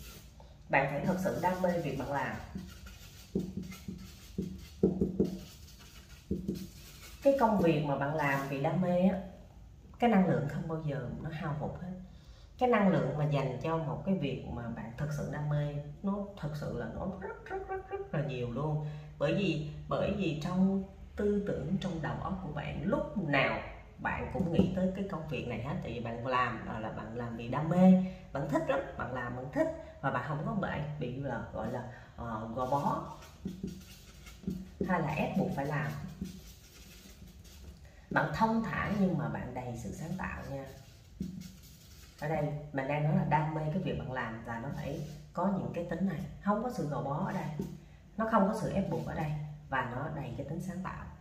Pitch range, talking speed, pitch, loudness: 130-185 Hz, 195 wpm, 155 Hz, -34 LUFS